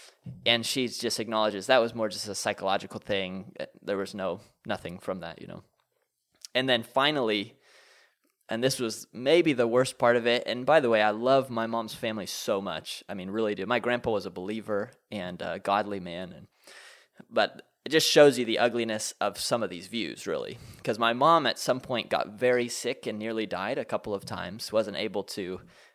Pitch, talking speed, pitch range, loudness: 115 Hz, 205 wpm, 105-125 Hz, -28 LUFS